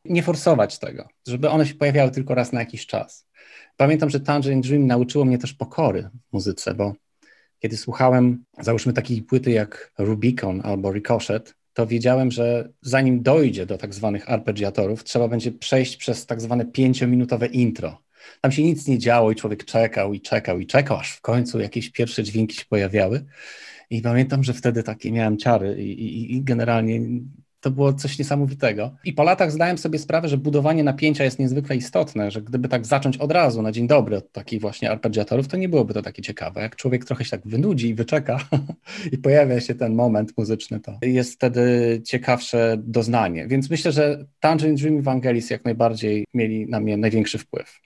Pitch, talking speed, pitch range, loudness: 120 Hz, 185 wpm, 110-135 Hz, -21 LUFS